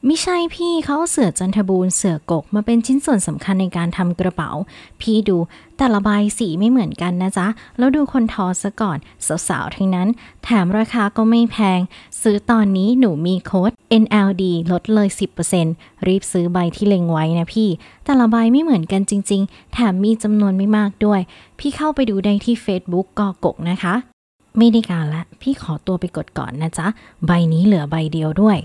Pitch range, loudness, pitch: 180-230 Hz, -18 LUFS, 200 Hz